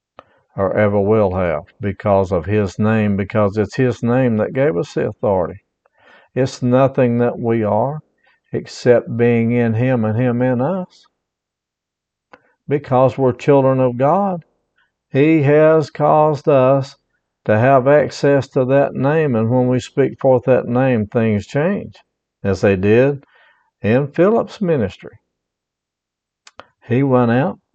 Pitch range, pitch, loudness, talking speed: 110-140 Hz, 125 Hz, -16 LUFS, 135 wpm